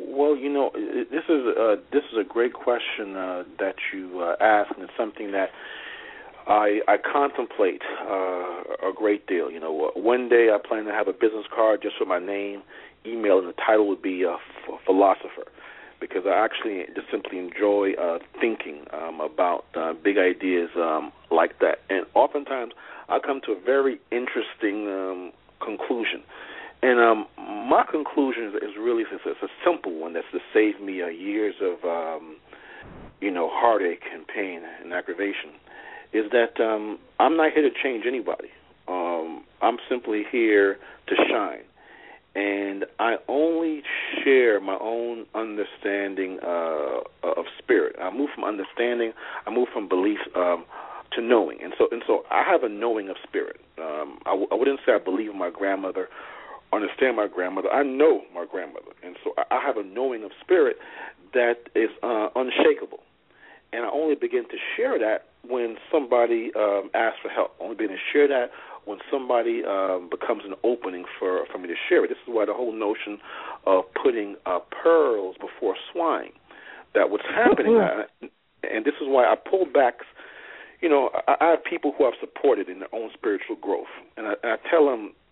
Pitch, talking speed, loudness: 145 Hz, 175 wpm, -24 LUFS